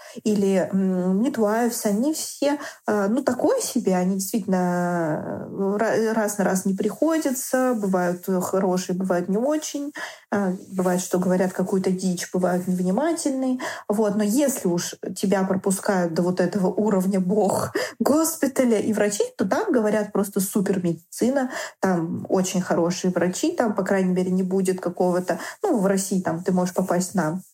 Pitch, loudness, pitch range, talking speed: 195 Hz, -23 LUFS, 185-235 Hz, 145 wpm